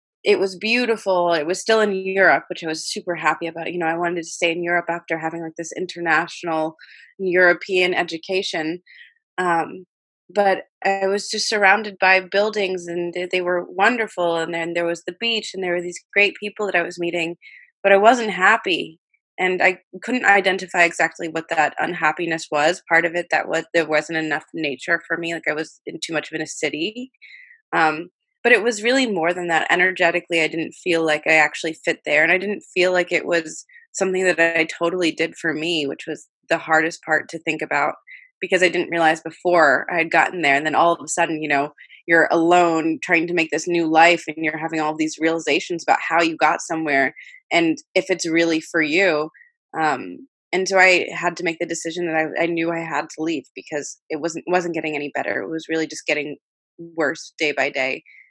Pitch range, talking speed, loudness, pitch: 160-190 Hz, 210 wpm, -20 LUFS, 170 Hz